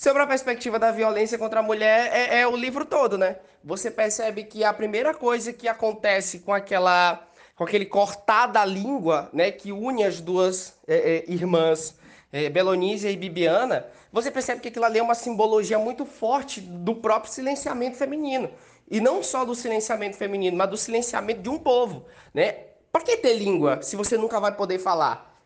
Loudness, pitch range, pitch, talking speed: -24 LUFS, 195-240 Hz, 220 Hz, 185 wpm